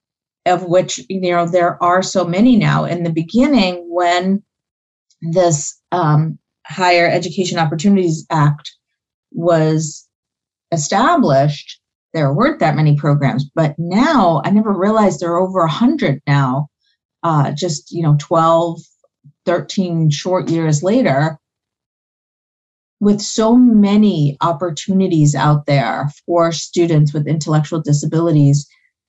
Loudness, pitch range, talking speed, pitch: -15 LUFS, 150-185 Hz, 120 wpm, 170 Hz